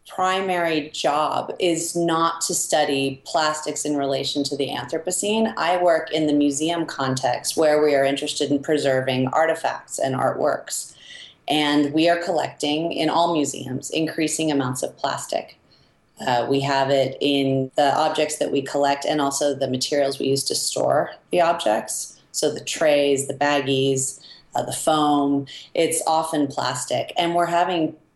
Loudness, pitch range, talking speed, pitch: -22 LUFS, 140-160 Hz, 155 wpm, 150 Hz